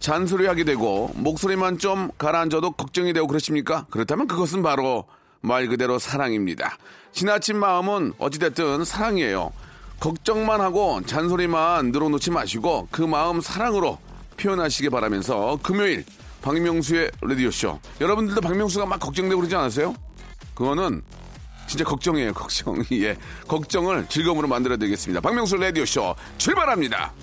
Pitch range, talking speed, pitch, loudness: 135-190 Hz, 370 characters per minute, 165 Hz, -23 LUFS